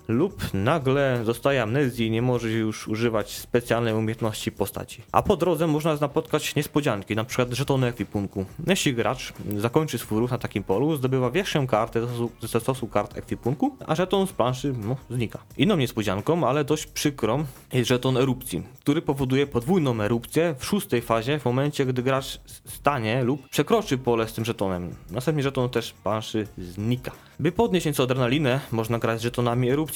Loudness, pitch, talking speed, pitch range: -25 LUFS, 125 Hz, 170 wpm, 115-145 Hz